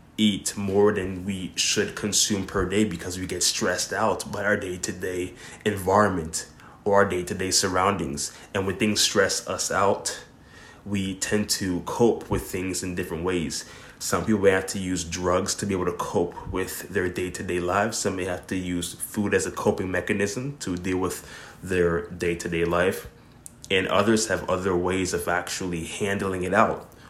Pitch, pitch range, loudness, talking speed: 95 Hz, 90-100 Hz, -25 LUFS, 175 wpm